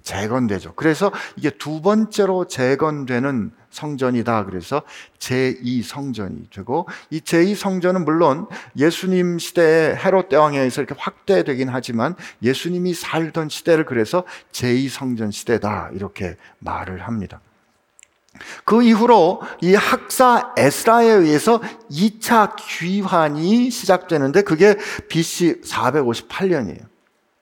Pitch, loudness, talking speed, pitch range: 160 Hz, -18 LUFS, 250 characters per minute, 130-195 Hz